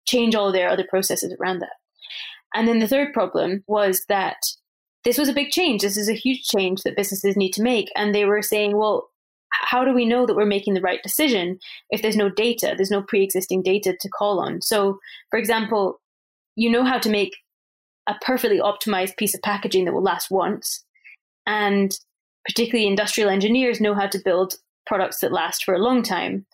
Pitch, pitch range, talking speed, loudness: 210 Hz, 195-235 Hz, 200 wpm, -21 LUFS